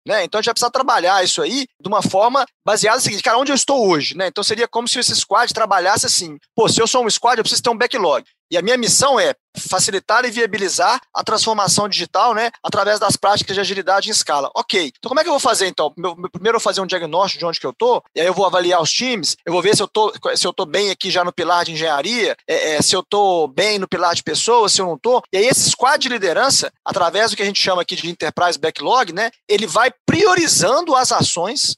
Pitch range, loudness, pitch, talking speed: 180-240 Hz, -16 LUFS, 205 Hz, 260 wpm